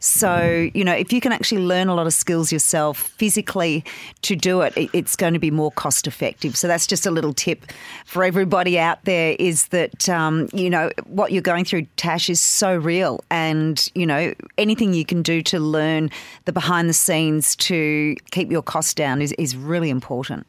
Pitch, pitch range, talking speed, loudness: 170 Hz, 155-185 Hz, 200 wpm, -19 LUFS